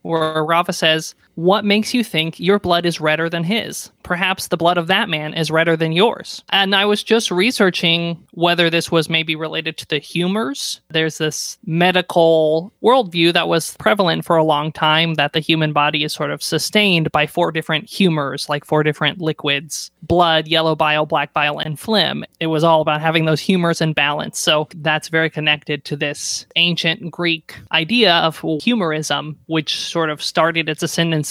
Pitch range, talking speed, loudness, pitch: 155-175 Hz, 185 wpm, -17 LUFS, 160 Hz